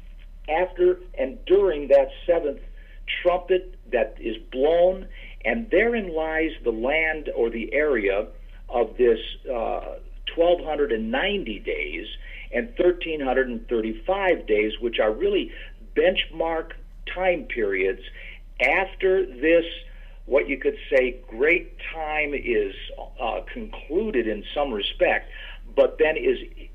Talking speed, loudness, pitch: 125 wpm, -24 LUFS, 190 Hz